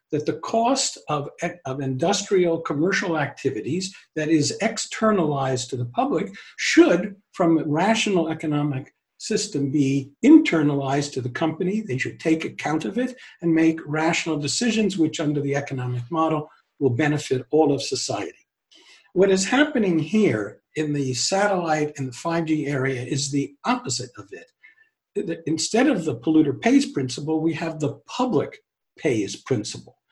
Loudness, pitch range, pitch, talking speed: -23 LUFS, 145-195 Hz, 160 Hz, 145 wpm